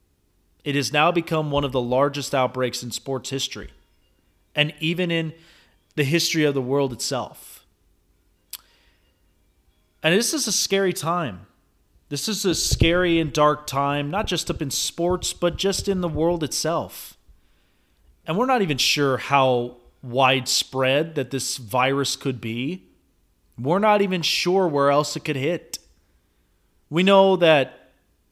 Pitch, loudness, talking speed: 135 Hz, -22 LUFS, 145 wpm